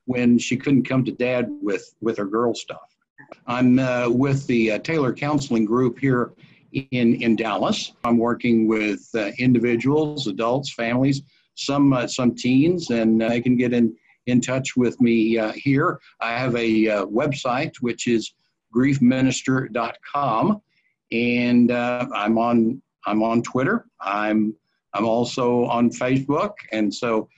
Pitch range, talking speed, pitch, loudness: 115-130 Hz, 145 wpm, 120 Hz, -21 LUFS